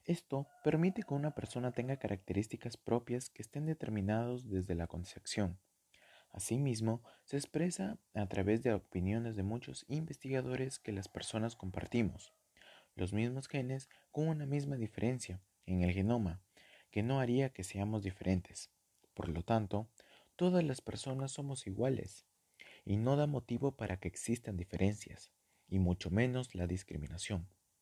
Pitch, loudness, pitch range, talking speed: 110 Hz, -38 LUFS, 95-130 Hz, 140 wpm